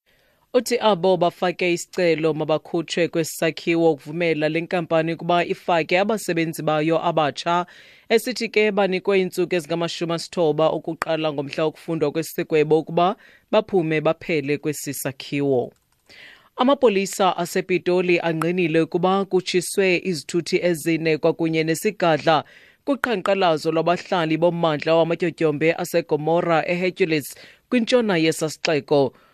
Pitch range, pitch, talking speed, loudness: 160-185 Hz, 170 Hz, 90 wpm, -21 LUFS